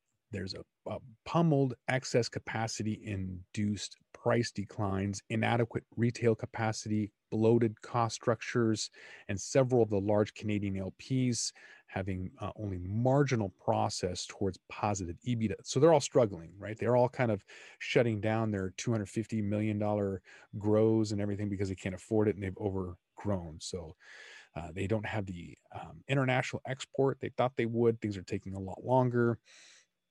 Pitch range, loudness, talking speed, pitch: 100-120 Hz, -32 LUFS, 145 wpm, 110 Hz